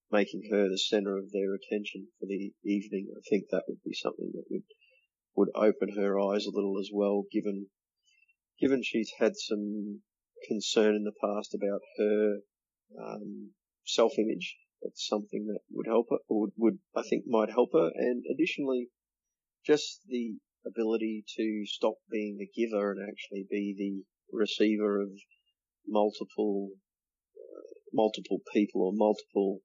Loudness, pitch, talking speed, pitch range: -31 LUFS, 105 Hz, 155 wpm, 100-110 Hz